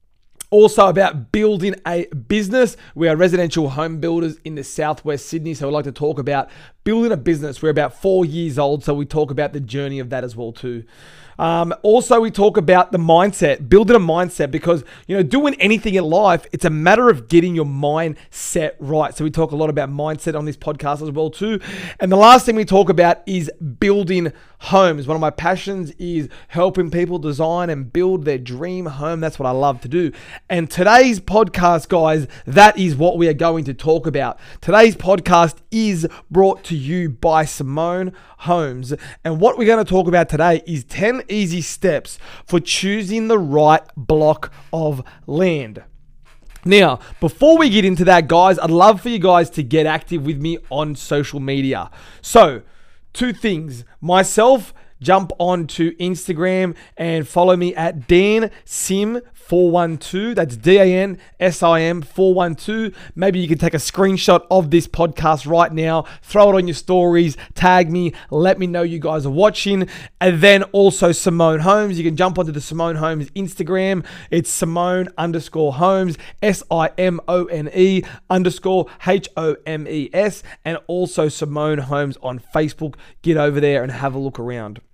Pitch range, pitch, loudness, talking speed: 155-185 Hz, 170 Hz, -16 LUFS, 170 wpm